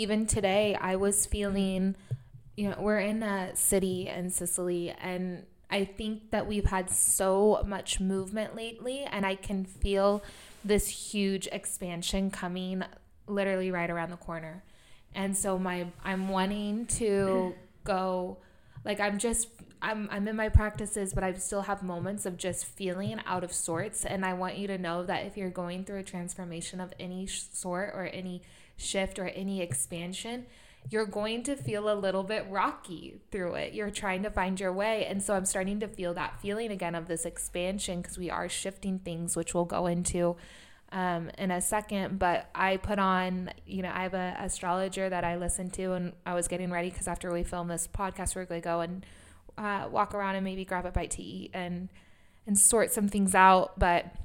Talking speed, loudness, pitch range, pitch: 190 wpm, -31 LUFS, 180-200 Hz, 190 Hz